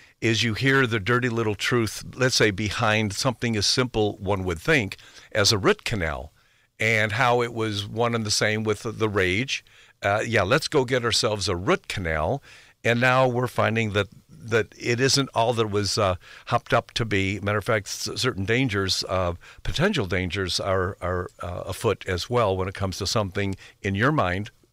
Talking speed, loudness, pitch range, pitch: 190 wpm, -24 LUFS, 100-120 Hz, 110 Hz